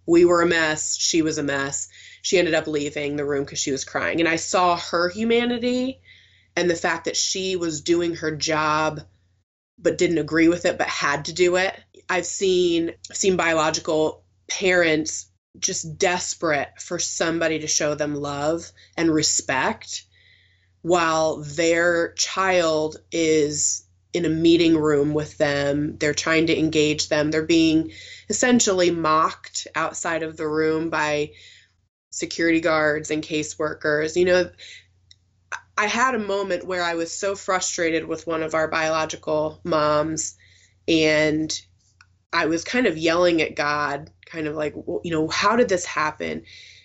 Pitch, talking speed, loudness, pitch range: 160 Hz, 155 wpm, -22 LUFS, 150-170 Hz